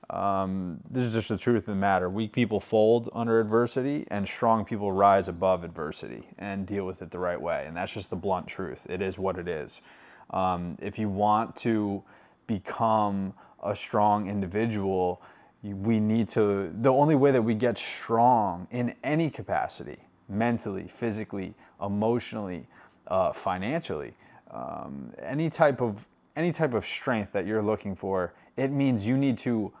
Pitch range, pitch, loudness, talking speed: 95-115 Hz, 105 Hz, -28 LUFS, 165 wpm